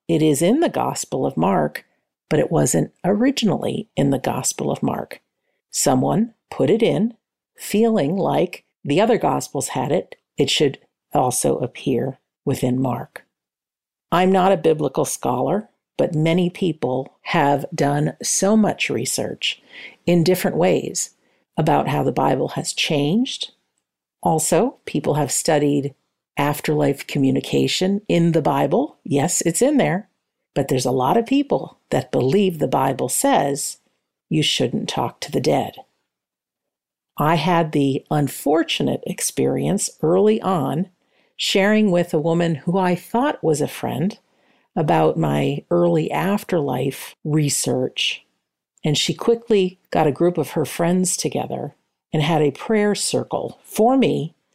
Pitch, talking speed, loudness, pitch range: 170 Hz, 135 wpm, -20 LUFS, 145-200 Hz